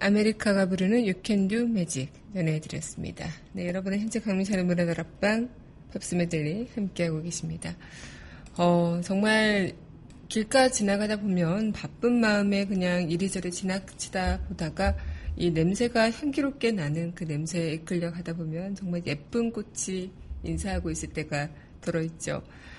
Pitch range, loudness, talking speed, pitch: 160-205 Hz, -28 LUFS, 315 characters per minute, 180 Hz